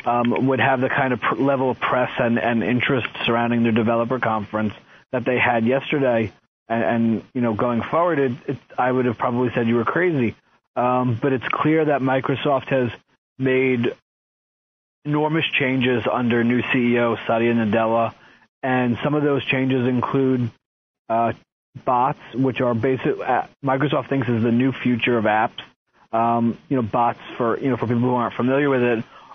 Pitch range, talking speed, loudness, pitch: 115-135 Hz, 175 wpm, -21 LUFS, 125 Hz